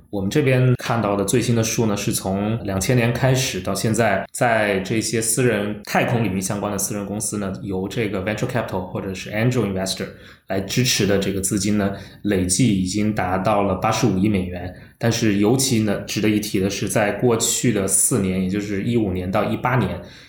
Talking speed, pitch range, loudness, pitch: 360 characters per minute, 95-115 Hz, -20 LUFS, 105 Hz